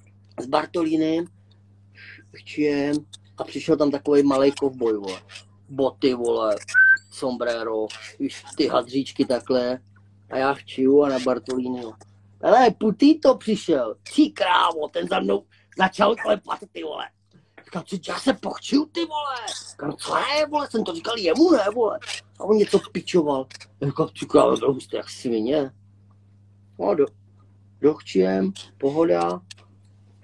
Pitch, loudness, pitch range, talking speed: 130 Hz, -22 LUFS, 100-160 Hz, 125 wpm